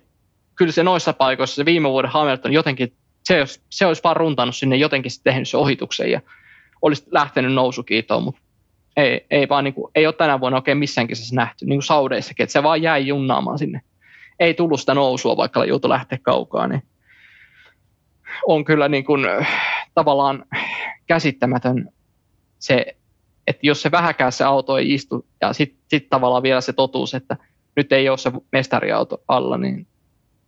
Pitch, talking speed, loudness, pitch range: 135 Hz, 165 wpm, -19 LUFS, 125-150 Hz